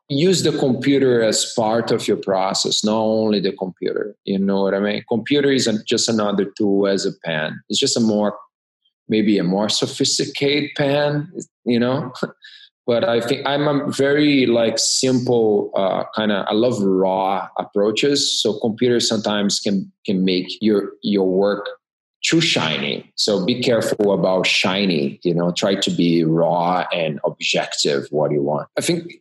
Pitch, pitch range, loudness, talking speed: 110 Hz, 100-140 Hz, -19 LUFS, 165 wpm